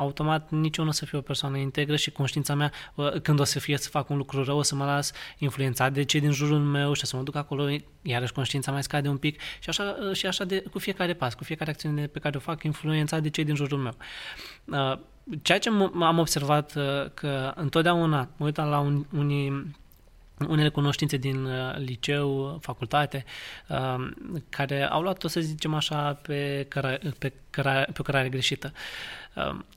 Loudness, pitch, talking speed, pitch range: -28 LUFS, 145 Hz, 180 wpm, 140-155 Hz